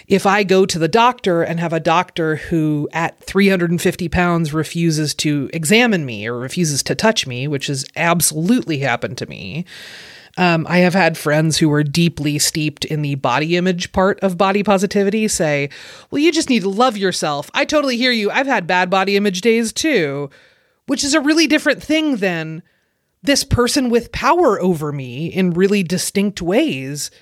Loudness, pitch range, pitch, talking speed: -16 LUFS, 155-205 Hz, 180 Hz, 180 wpm